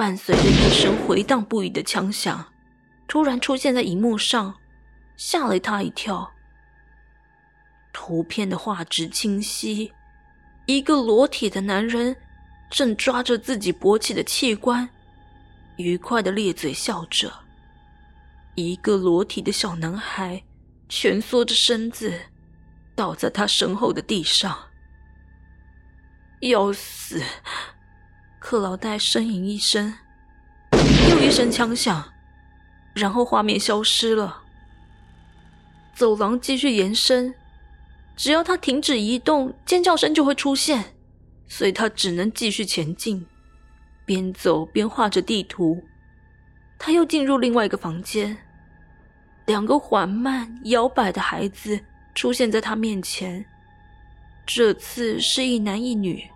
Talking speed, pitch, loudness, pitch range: 175 characters per minute, 205 Hz, -21 LUFS, 160-240 Hz